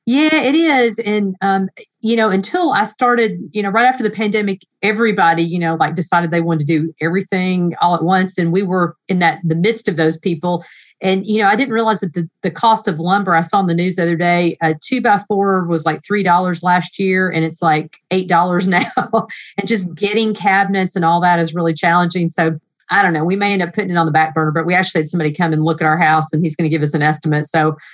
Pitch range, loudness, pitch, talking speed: 165-205 Hz, -15 LUFS, 180 Hz, 250 wpm